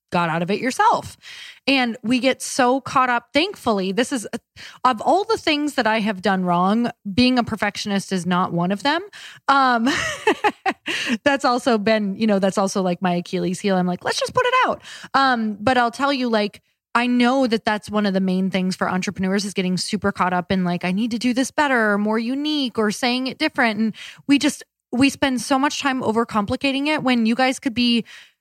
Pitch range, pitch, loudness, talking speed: 200-270 Hz, 235 Hz, -20 LUFS, 215 wpm